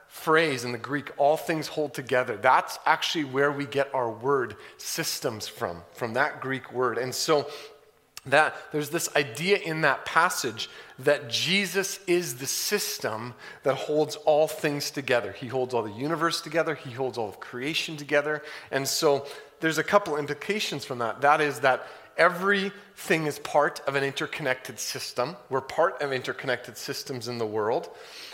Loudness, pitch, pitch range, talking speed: -27 LUFS, 145 Hz, 130-160 Hz, 165 wpm